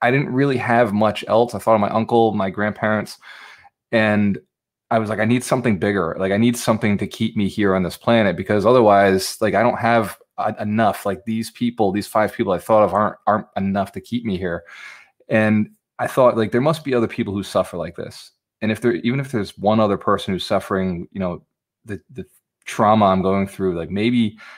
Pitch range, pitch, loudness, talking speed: 100-115 Hz, 110 Hz, -19 LUFS, 220 wpm